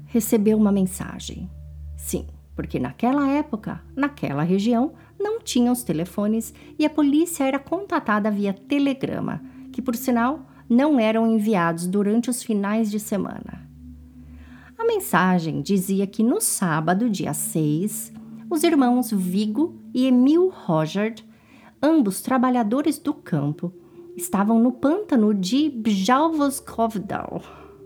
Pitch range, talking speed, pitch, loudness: 185-270 Hz, 115 wpm, 220 Hz, -22 LUFS